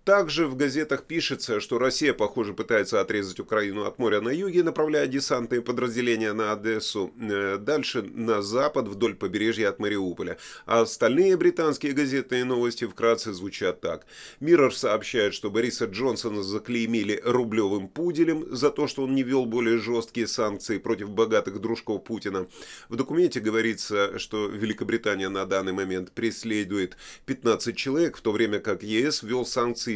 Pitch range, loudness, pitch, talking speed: 105-135 Hz, -26 LUFS, 115 Hz, 145 wpm